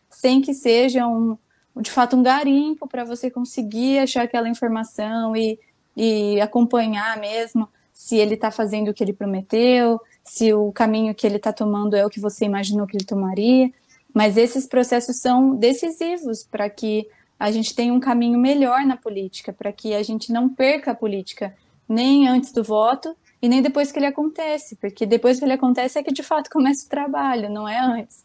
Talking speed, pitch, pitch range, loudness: 190 wpm, 235 Hz, 215-260 Hz, -20 LUFS